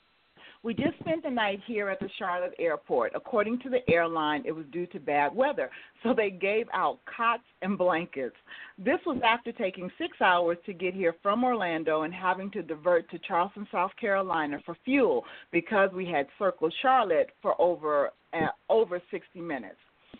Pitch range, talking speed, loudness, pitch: 170-235 Hz, 175 wpm, -29 LUFS, 195 Hz